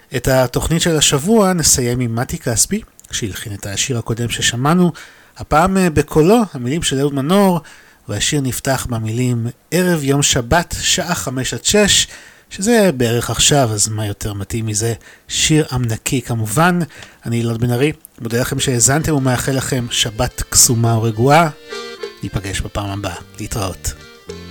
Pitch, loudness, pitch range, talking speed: 125 Hz, -16 LUFS, 115-150 Hz, 135 wpm